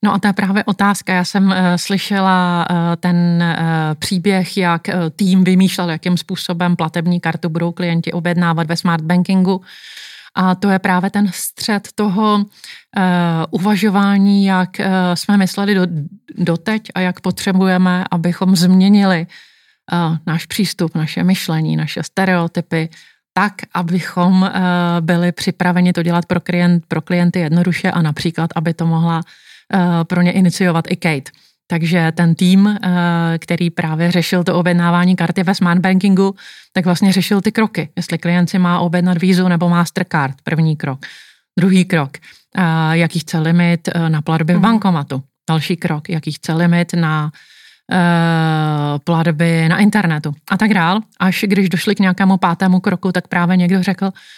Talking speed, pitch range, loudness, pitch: 140 wpm, 170-190 Hz, -15 LUFS, 180 Hz